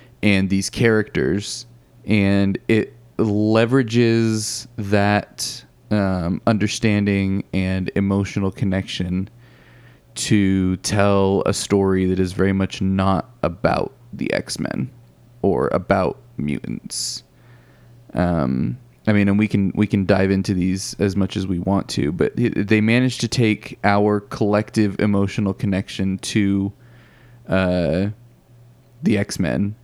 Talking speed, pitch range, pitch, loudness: 120 wpm, 95-115 Hz, 100 Hz, -20 LUFS